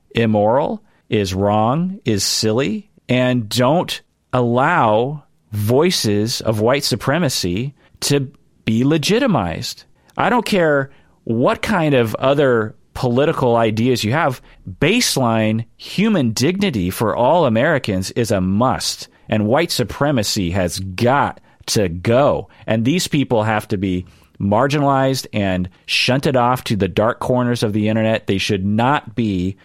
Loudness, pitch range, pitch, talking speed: -17 LUFS, 105-140 Hz, 120 Hz, 130 wpm